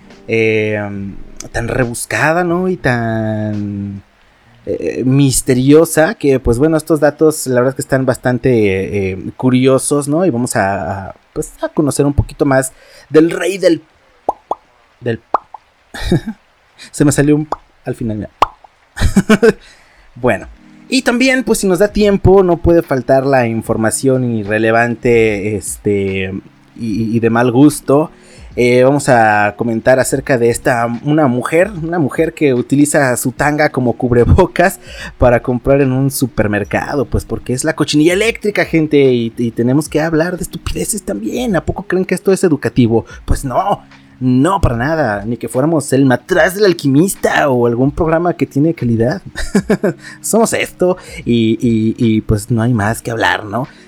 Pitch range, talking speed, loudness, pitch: 115-160 Hz, 155 wpm, -14 LUFS, 130 Hz